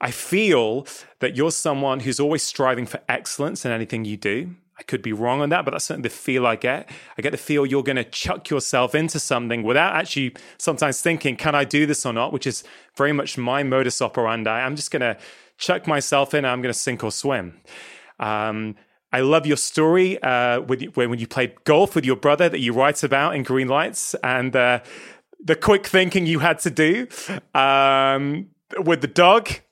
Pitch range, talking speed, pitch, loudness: 125-155 Hz, 210 wpm, 140 Hz, -21 LUFS